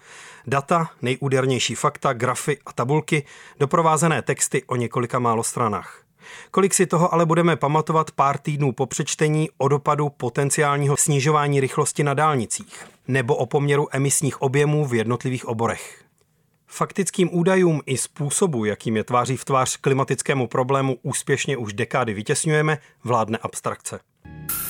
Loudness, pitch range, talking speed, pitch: -21 LUFS, 125-155 Hz, 130 wpm, 140 Hz